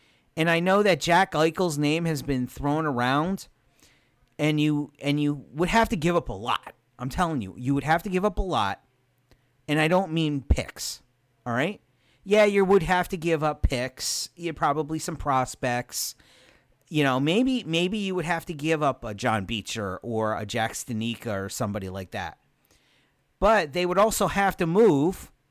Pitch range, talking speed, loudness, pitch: 125-175 Hz, 190 wpm, -25 LUFS, 150 Hz